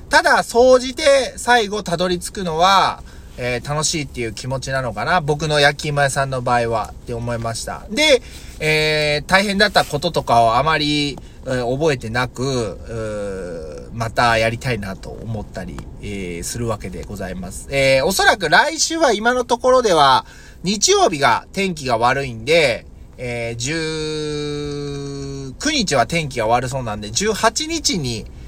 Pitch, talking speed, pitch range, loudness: 140 Hz, 285 characters per minute, 120-185 Hz, -18 LUFS